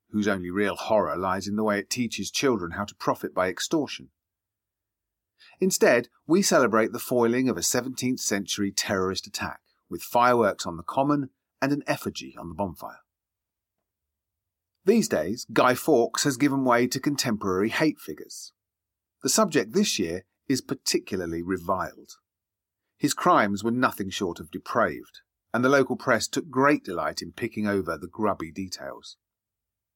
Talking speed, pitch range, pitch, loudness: 150 wpm, 95-130 Hz, 105 Hz, -25 LUFS